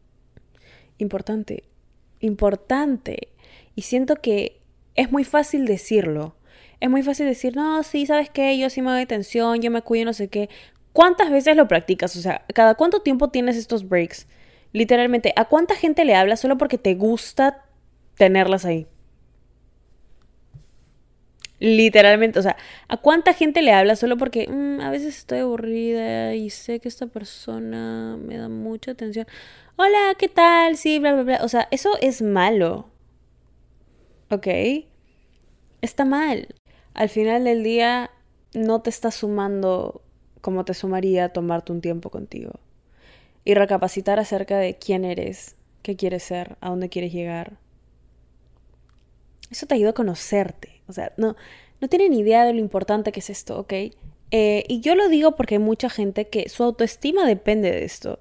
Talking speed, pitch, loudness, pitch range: 155 wpm, 220 Hz, -20 LUFS, 185-255 Hz